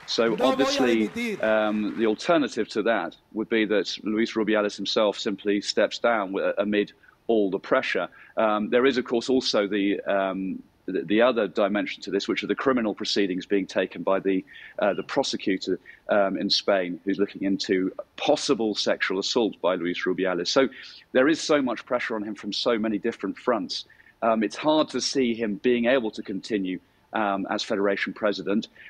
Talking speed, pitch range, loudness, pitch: 175 wpm, 100-115 Hz, -25 LUFS, 105 Hz